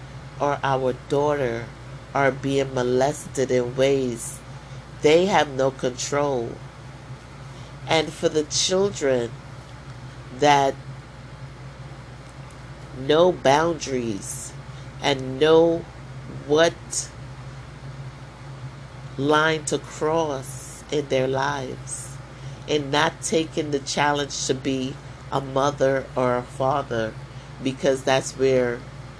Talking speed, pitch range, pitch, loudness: 90 wpm, 130-140 Hz, 135 Hz, -23 LUFS